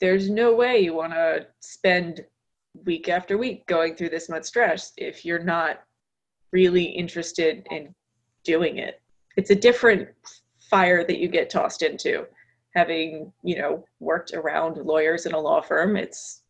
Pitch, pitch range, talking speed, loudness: 175 Hz, 165-200 Hz, 155 wpm, -23 LUFS